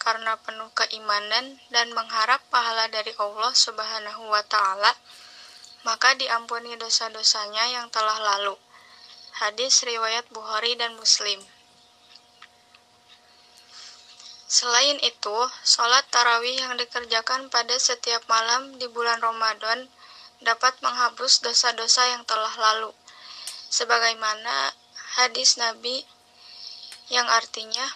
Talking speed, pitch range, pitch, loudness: 95 wpm, 220-245 Hz, 230 Hz, -22 LUFS